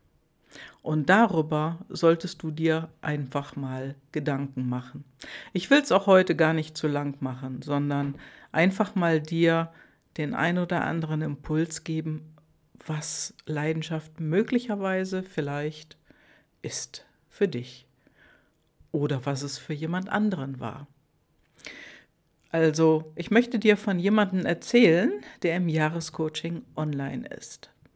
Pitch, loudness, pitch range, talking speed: 160 Hz, -26 LUFS, 145-175 Hz, 120 wpm